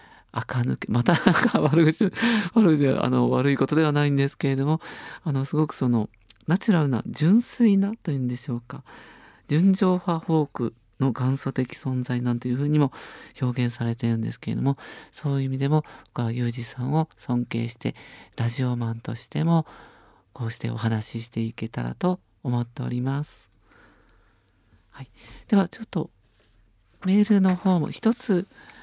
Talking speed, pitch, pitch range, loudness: 315 characters per minute, 135 Hz, 120-160 Hz, -24 LUFS